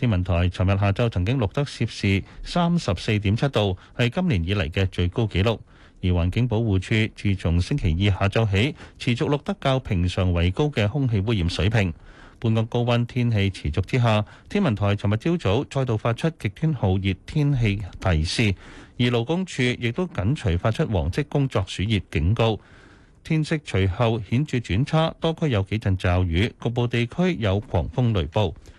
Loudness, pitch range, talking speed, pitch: -23 LUFS, 95-125 Hz, 270 characters per minute, 110 Hz